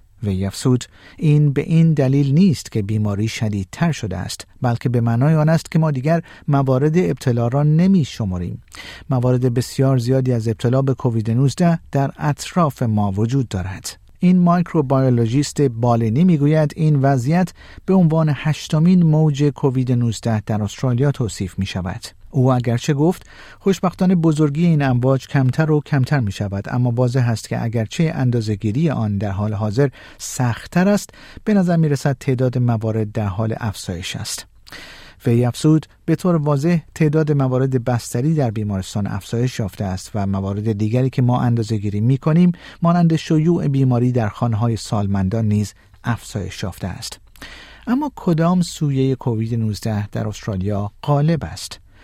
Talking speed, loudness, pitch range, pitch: 150 wpm, -18 LUFS, 110-155 Hz, 130 Hz